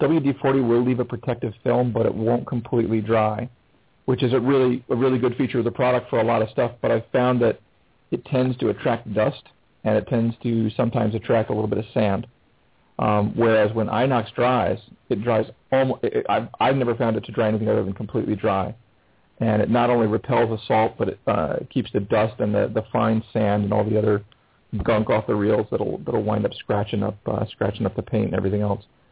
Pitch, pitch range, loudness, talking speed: 115 Hz, 110-125 Hz, -22 LUFS, 225 wpm